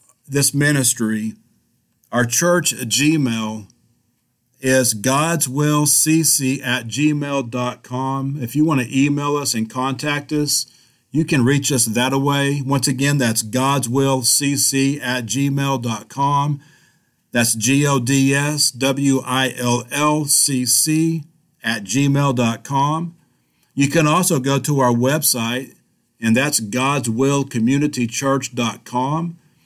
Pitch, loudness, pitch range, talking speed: 135 Hz, -18 LUFS, 125-145 Hz, 95 wpm